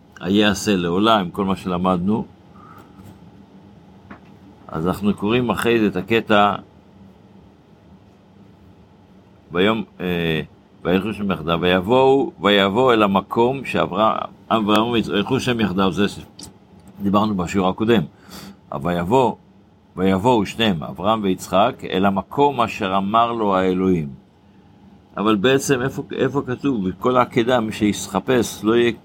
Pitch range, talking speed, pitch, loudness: 95-115 Hz, 110 wpm, 100 Hz, -19 LUFS